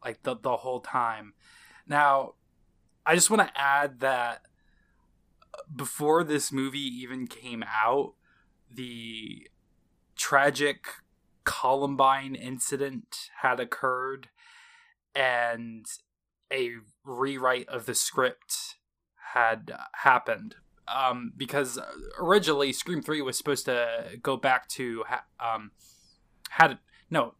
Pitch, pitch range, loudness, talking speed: 130 Hz, 115-145 Hz, -27 LUFS, 105 wpm